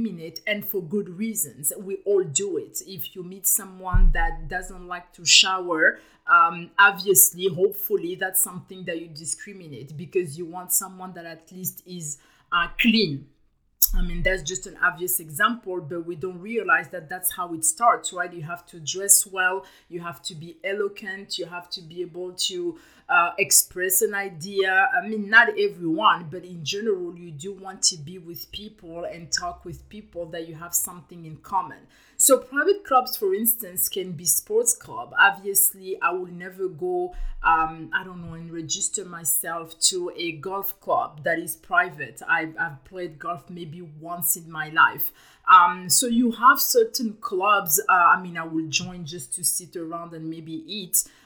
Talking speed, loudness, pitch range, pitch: 180 wpm, -22 LUFS, 170-200 Hz, 180 Hz